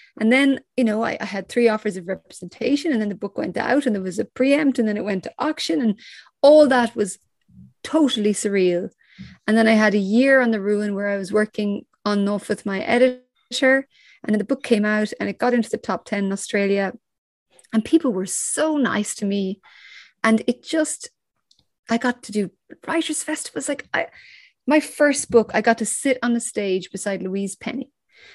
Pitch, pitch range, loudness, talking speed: 225 Hz, 205-270 Hz, -21 LUFS, 205 wpm